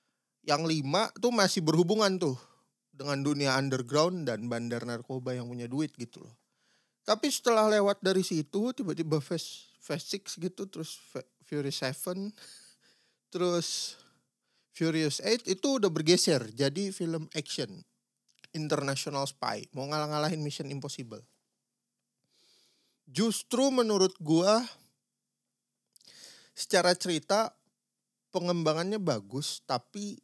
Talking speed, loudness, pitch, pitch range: 105 wpm, -30 LUFS, 160 Hz, 140-195 Hz